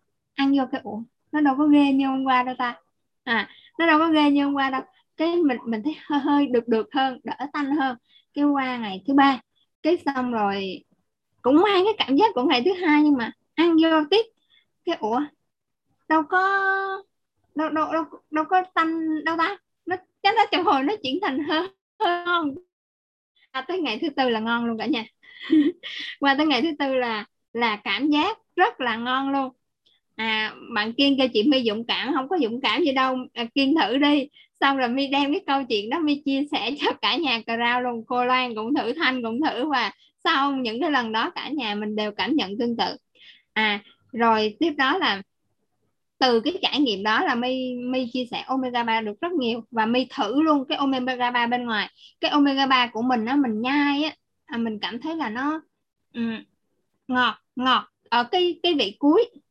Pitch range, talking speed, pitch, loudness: 245-315 Hz, 205 wpm, 275 Hz, -23 LUFS